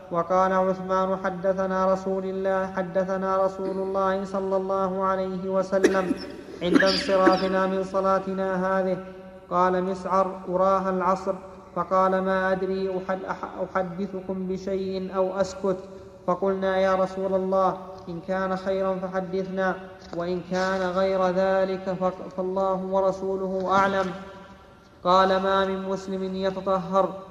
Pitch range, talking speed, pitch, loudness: 185-190 Hz, 110 wpm, 190 Hz, -25 LUFS